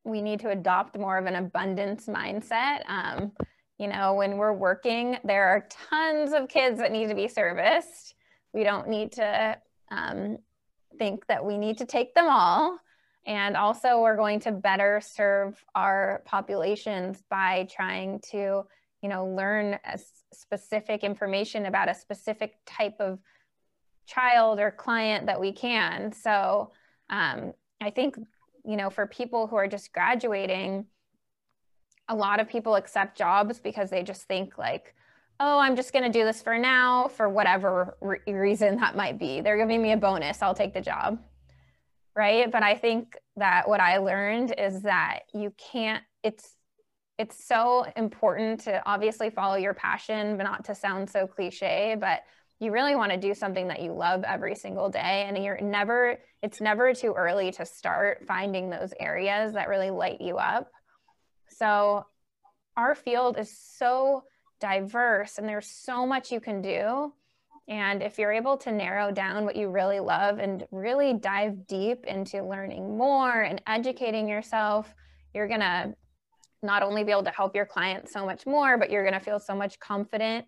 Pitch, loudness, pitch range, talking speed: 210 Hz, -27 LUFS, 195-230 Hz, 170 wpm